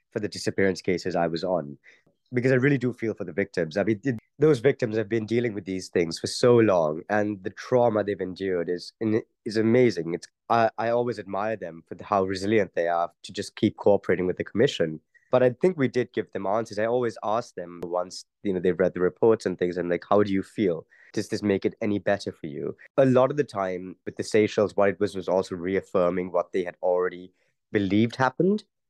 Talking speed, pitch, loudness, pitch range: 230 wpm, 105 Hz, -25 LUFS, 90-115 Hz